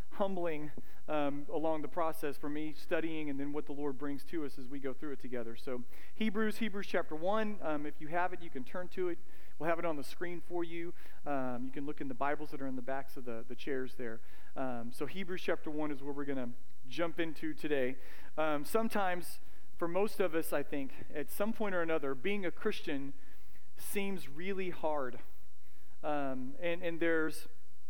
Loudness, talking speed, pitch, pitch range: -39 LUFS, 210 wpm, 150 Hz, 135-170 Hz